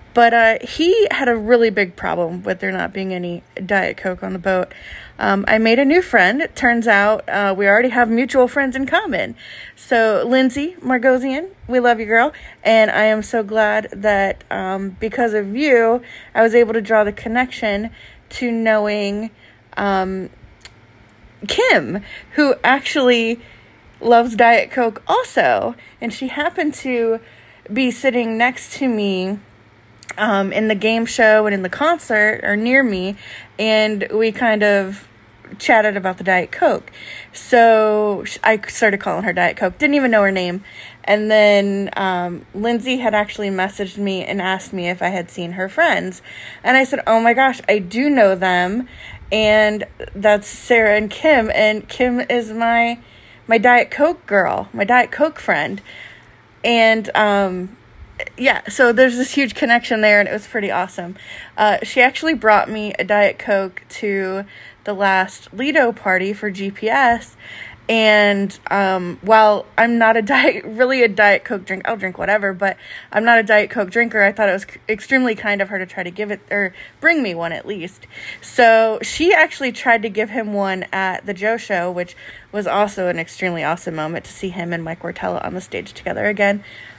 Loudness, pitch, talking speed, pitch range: -16 LUFS, 215 Hz, 175 wpm, 195-240 Hz